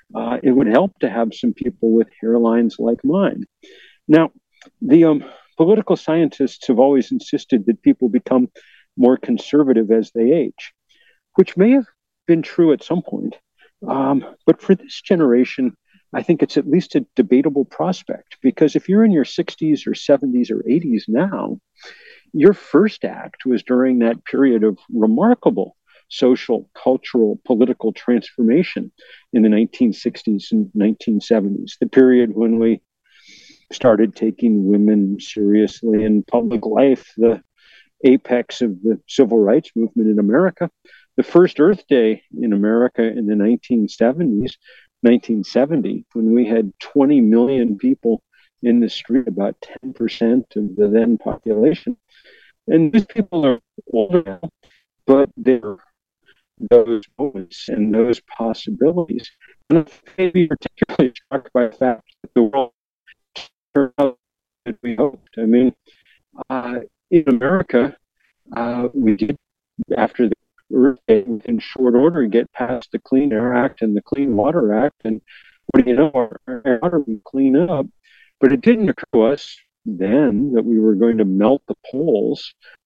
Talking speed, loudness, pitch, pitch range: 145 wpm, -17 LUFS, 125 Hz, 115-155 Hz